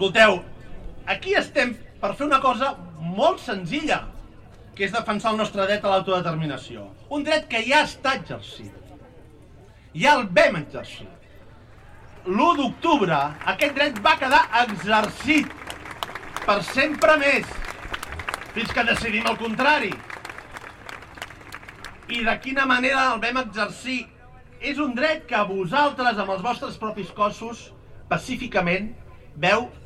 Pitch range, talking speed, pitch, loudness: 170-270 Hz, 125 wpm, 215 Hz, -22 LUFS